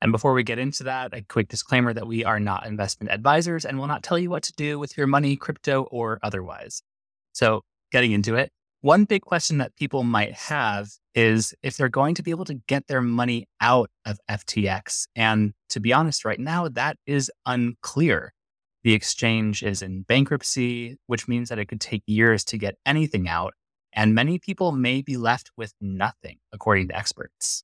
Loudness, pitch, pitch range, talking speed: -24 LUFS, 120 Hz, 105-140 Hz, 195 wpm